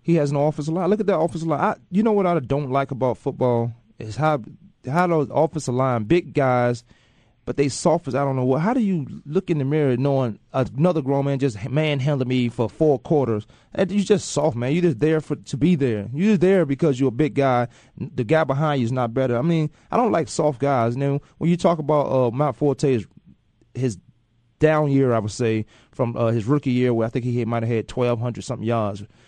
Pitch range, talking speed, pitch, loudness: 120-155 Hz, 250 wpm, 140 Hz, -21 LUFS